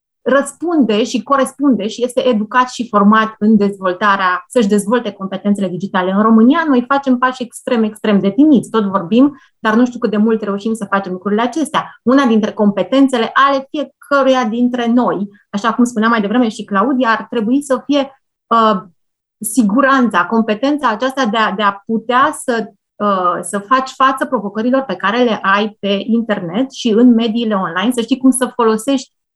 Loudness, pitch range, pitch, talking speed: -14 LUFS, 205-260 Hz, 230 Hz, 170 wpm